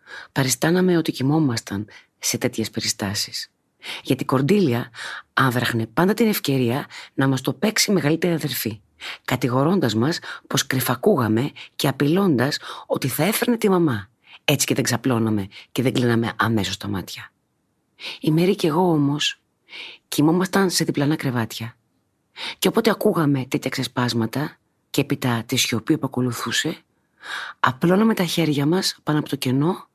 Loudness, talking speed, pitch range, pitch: -21 LUFS, 140 wpm, 120-165 Hz, 135 Hz